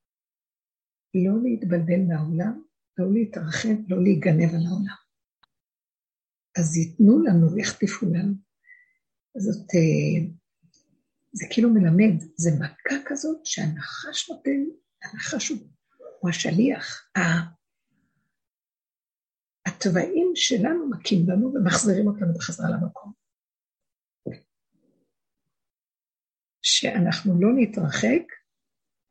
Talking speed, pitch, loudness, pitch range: 80 wpm, 200 Hz, -23 LUFS, 175-255 Hz